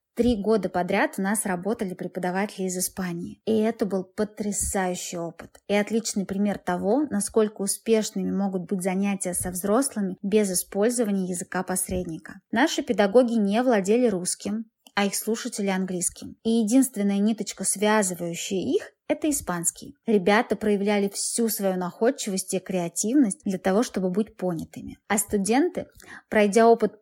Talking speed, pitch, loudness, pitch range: 135 wpm, 205 Hz, -25 LUFS, 190-225 Hz